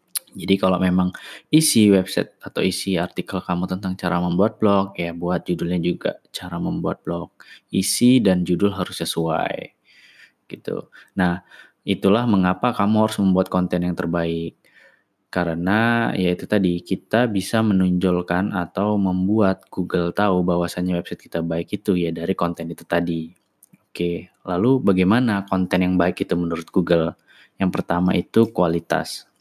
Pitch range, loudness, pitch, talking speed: 85-100 Hz, -21 LUFS, 90 Hz, 140 wpm